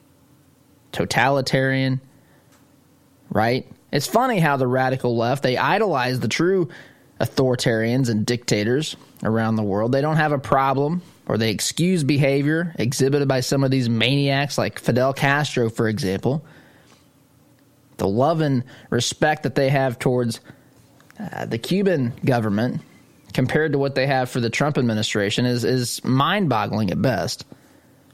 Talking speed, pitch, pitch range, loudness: 135 wpm, 135 Hz, 125-140 Hz, -21 LUFS